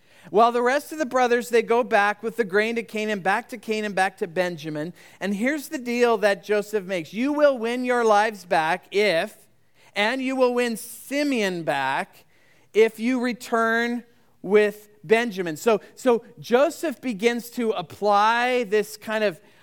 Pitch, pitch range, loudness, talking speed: 225 Hz, 205-245 Hz, -23 LUFS, 165 wpm